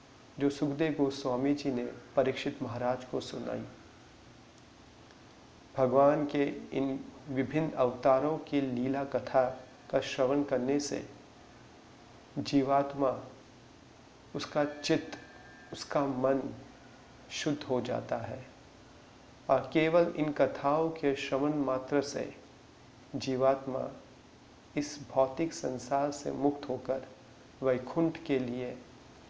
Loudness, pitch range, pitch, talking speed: -32 LUFS, 130-145 Hz, 135 Hz, 100 wpm